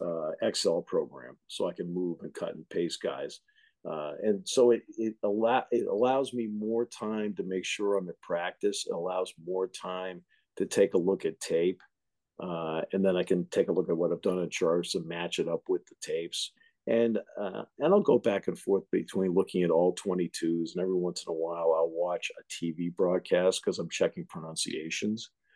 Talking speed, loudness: 205 wpm, -30 LUFS